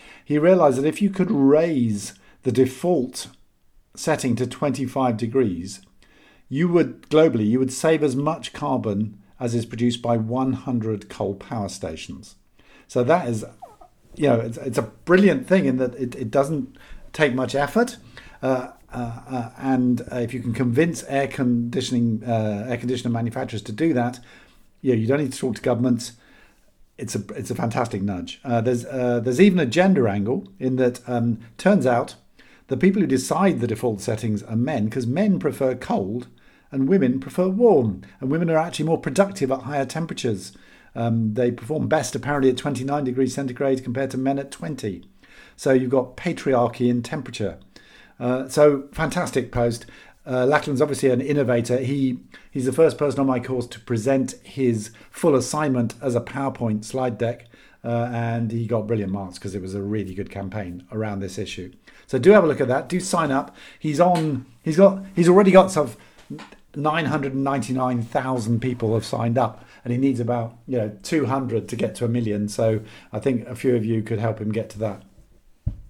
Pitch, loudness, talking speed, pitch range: 125 Hz, -22 LUFS, 185 wpm, 115-140 Hz